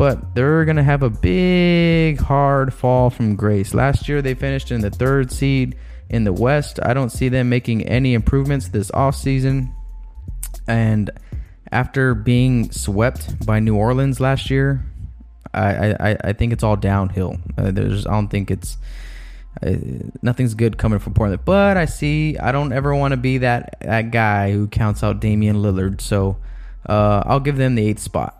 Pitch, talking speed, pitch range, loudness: 115 Hz, 175 wpm, 105-135 Hz, -18 LUFS